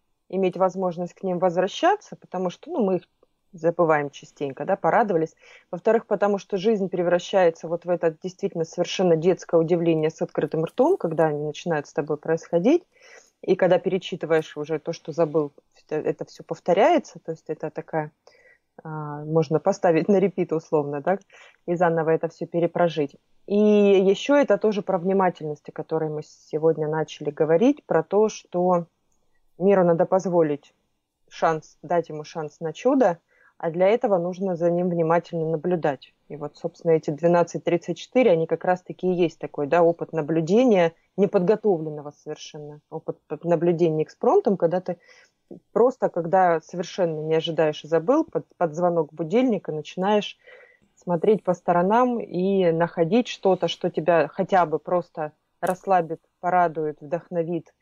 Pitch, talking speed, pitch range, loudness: 170 Hz, 145 wpm, 160-190 Hz, -23 LUFS